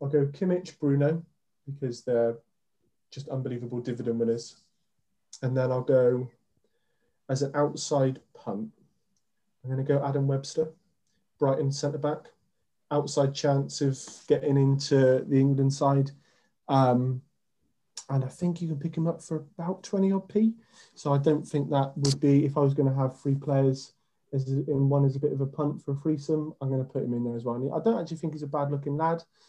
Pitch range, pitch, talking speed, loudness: 135-155 Hz, 140 Hz, 190 wpm, -28 LUFS